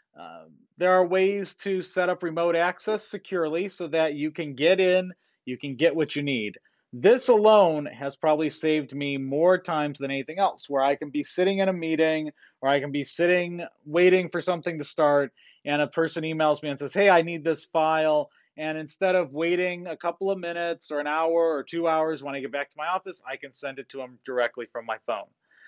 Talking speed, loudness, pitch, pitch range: 220 wpm, -25 LUFS, 160 Hz, 145-180 Hz